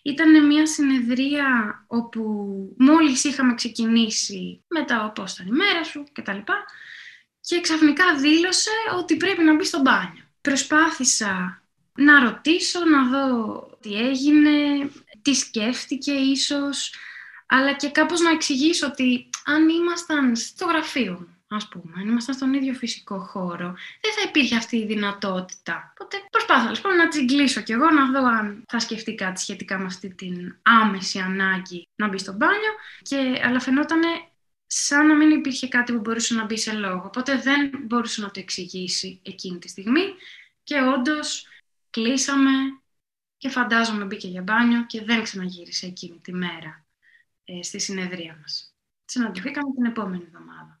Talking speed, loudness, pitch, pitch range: 150 wpm, -21 LUFS, 255 Hz, 205-295 Hz